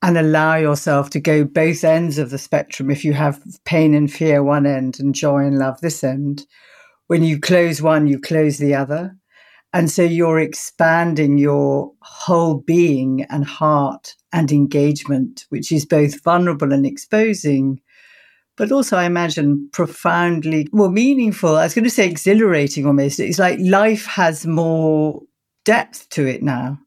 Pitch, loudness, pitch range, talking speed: 155 Hz, -17 LUFS, 140-170 Hz, 160 wpm